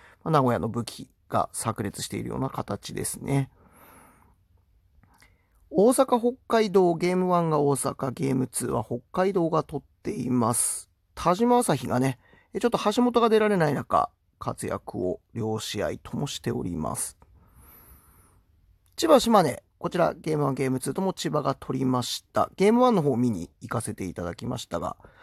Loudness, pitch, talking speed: -26 LUFS, 135 Hz, 290 characters per minute